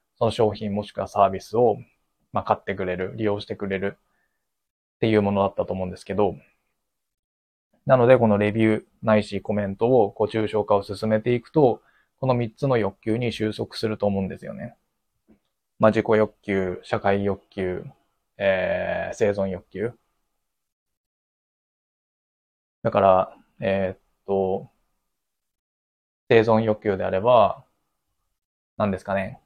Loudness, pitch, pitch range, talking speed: -23 LUFS, 100 Hz, 95-110 Hz, 255 characters per minute